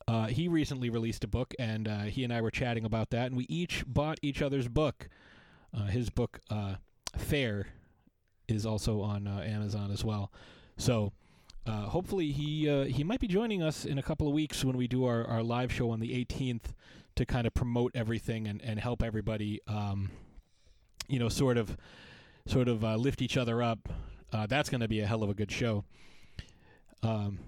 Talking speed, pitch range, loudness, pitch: 200 wpm, 105-130 Hz, -33 LUFS, 115 Hz